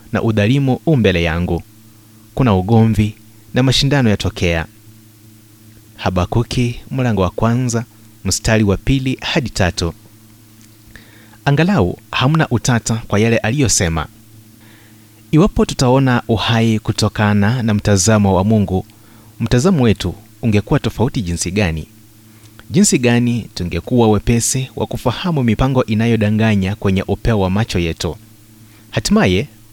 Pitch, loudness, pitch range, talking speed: 110 Hz, -16 LUFS, 105-120 Hz, 105 wpm